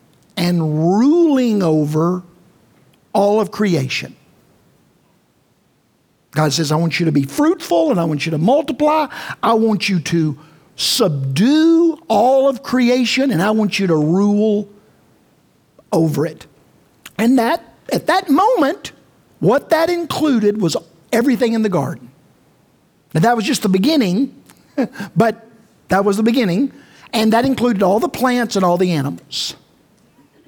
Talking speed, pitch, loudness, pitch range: 140 wpm, 210 Hz, -16 LUFS, 170-255 Hz